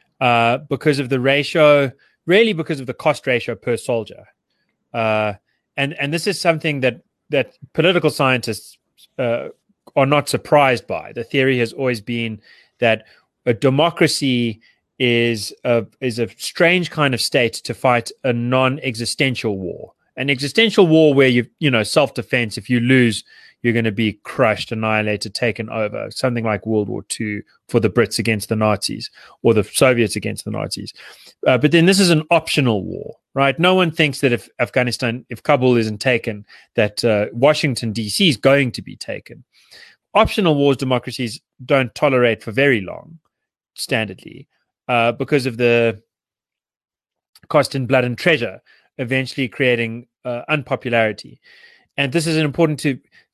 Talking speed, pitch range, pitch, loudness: 160 wpm, 115-145 Hz, 125 Hz, -18 LUFS